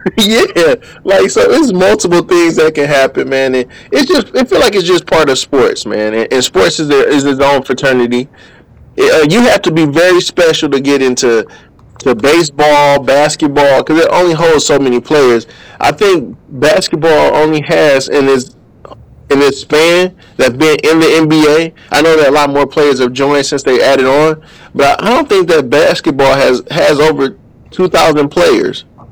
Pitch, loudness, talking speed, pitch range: 150 Hz, -9 LUFS, 190 wpm, 135-170 Hz